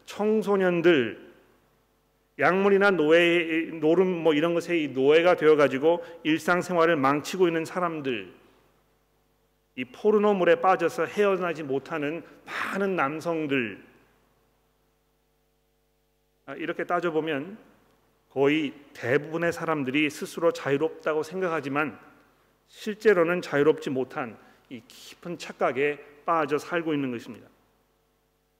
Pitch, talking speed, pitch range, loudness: 165 Hz, 245 characters per minute, 150-175 Hz, -25 LUFS